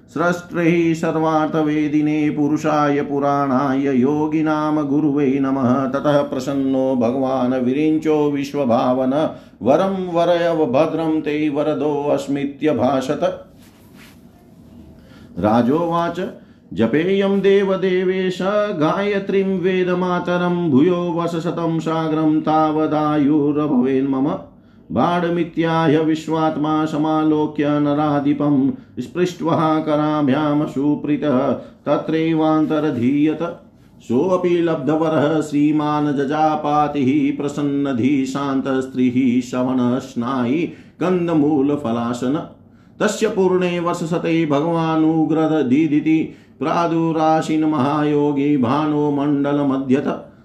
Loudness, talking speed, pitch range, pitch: -18 LUFS, 55 wpm, 145-165 Hz, 150 Hz